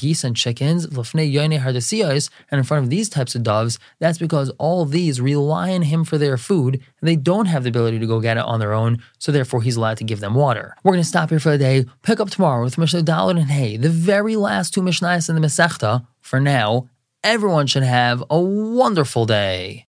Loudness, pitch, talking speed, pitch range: -19 LUFS, 145 Hz, 225 wpm, 125-170 Hz